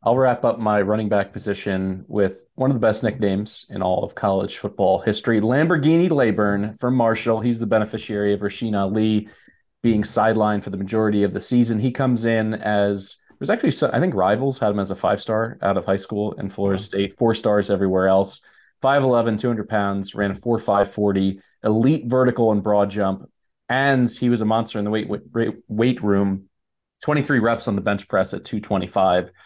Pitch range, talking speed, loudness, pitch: 100-115 Hz, 190 wpm, -21 LUFS, 105 Hz